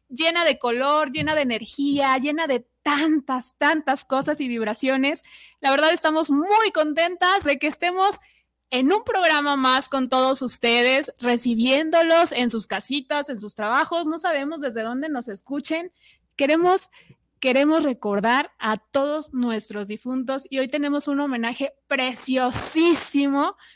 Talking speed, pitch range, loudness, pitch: 135 wpm, 255-310 Hz, -21 LUFS, 280 Hz